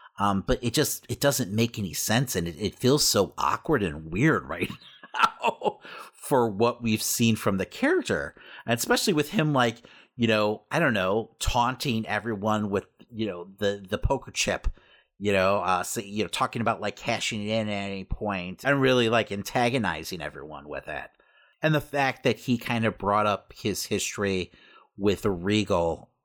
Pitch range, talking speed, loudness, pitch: 100-120 Hz, 185 wpm, -26 LUFS, 110 Hz